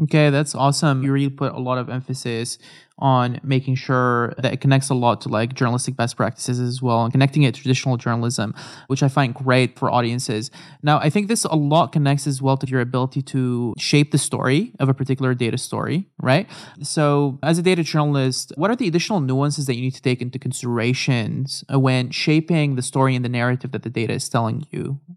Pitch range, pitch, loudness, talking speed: 125-145 Hz, 130 Hz, -20 LUFS, 210 wpm